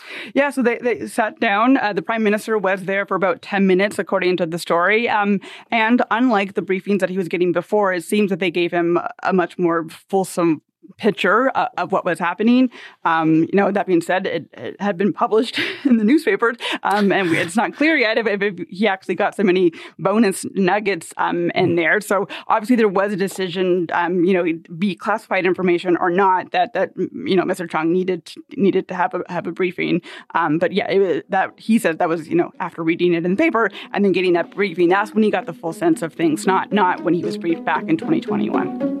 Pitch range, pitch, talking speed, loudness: 180-220 Hz, 195 Hz, 225 wpm, -19 LUFS